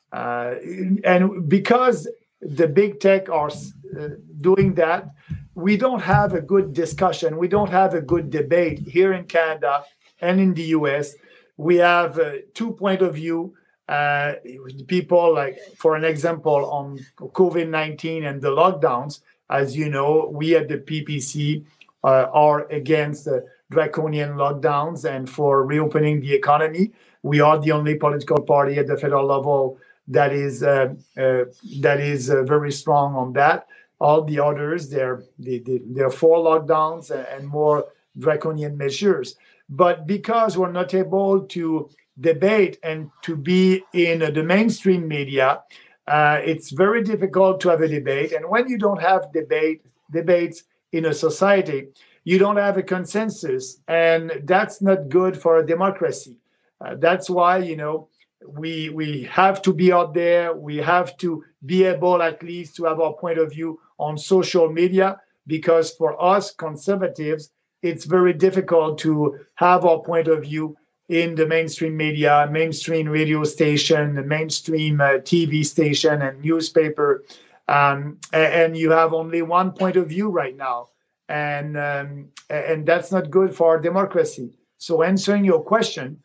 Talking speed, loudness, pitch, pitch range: 155 wpm, -20 LUFS, 160 Hz, 150-180 Hz